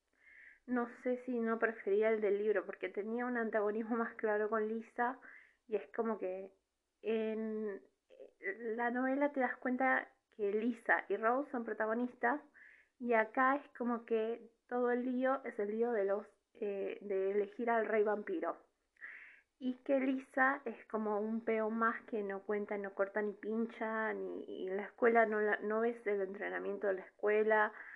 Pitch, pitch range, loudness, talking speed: 225 Hz, 210-245 Hz, -37 LUFS, 170 wpm